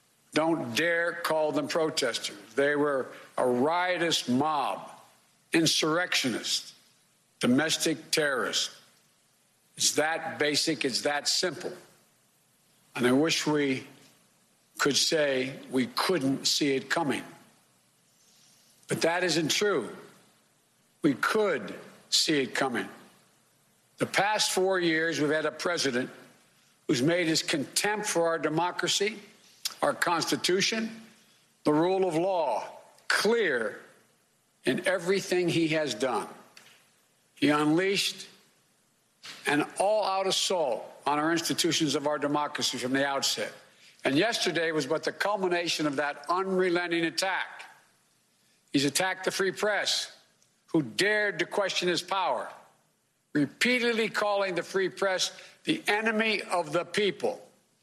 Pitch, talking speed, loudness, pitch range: 170 Hz, 115 wpm, -27 LUFS, 150-190 Hz